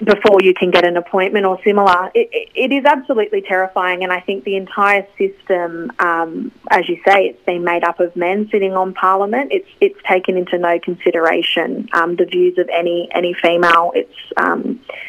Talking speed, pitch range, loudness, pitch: 190 wpm, 175-205 Hz, -15 LUFS, 185 Hz